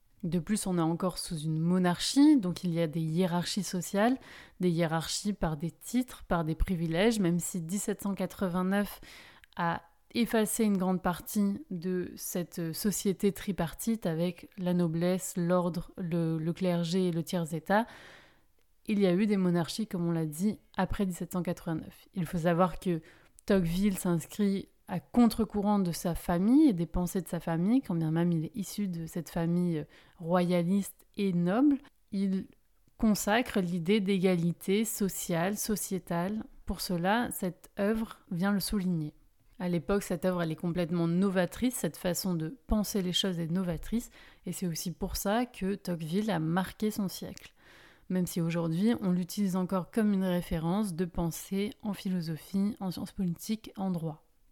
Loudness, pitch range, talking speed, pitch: -31 LUFS, 175-205 Hz, 160 wpm, 185 Hz